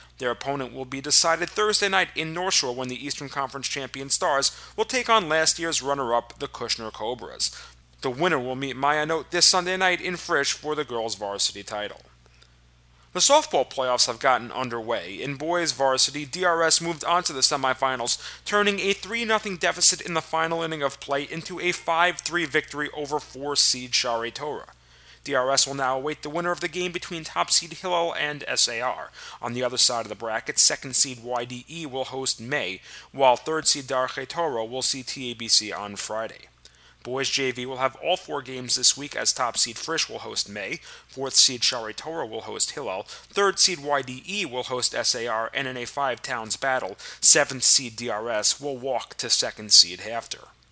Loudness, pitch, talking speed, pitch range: -23 LUFS, 135 Hz, 185 wpm, 125-165 Hz